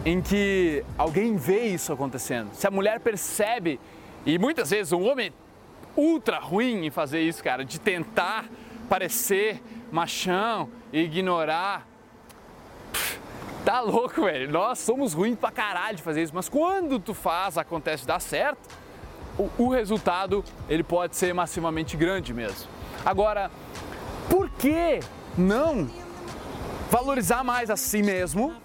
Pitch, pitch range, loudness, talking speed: 195 Hz, 170-230 Hz, -26 LUFS, 135 wpm